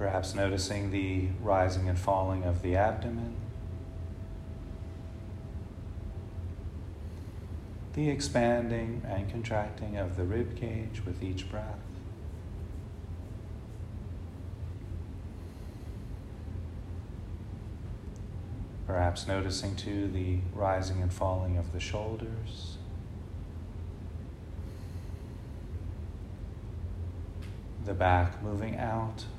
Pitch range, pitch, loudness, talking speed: 90-105 Hz, 95 Hz, -35 LUFS, 70 wpm